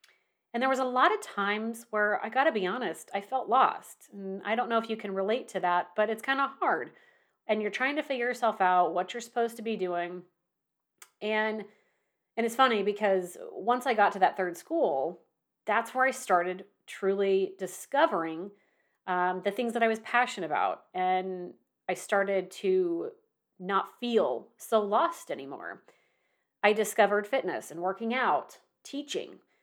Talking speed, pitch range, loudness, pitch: 170 wpm, 190-250 Hz, -29 LUFS, 215 Hz